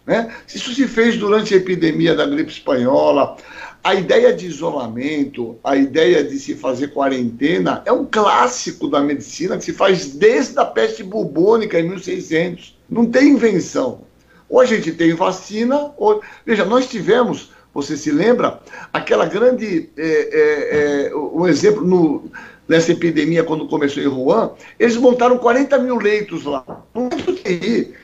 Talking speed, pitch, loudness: 150 wpm, 225 Hz, -16 LUFS